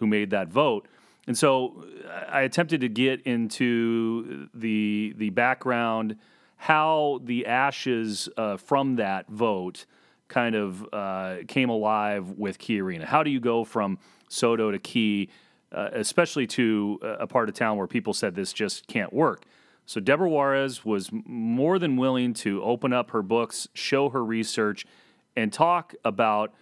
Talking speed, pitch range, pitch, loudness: 155 wpm, 105-130 Hz, 115 Hz, -26 LUFS